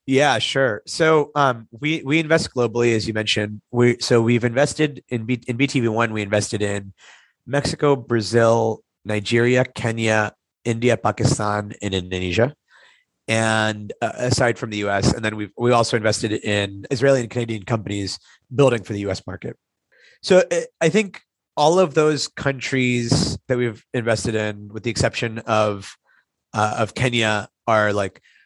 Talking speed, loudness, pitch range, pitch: 150 wpm, -20 LUFS, 105-130 Hz, 115 Hz